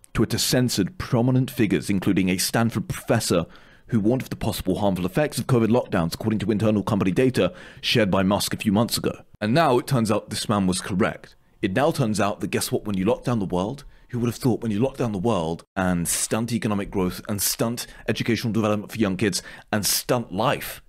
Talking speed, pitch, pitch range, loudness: 220 wpm, 110 Hz, 95-120 Hz, -23 LUFS